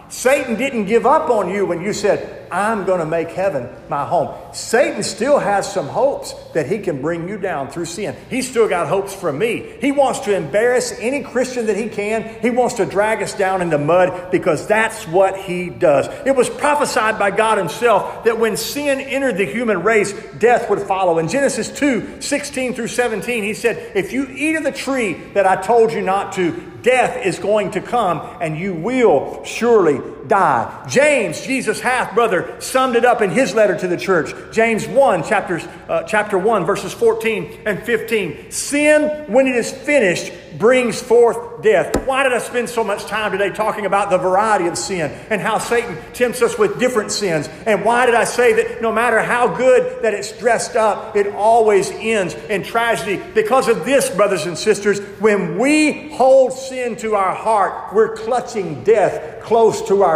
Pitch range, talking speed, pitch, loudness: 200-255 Hz, 195 wpm, 220 Hz, -17 LUFS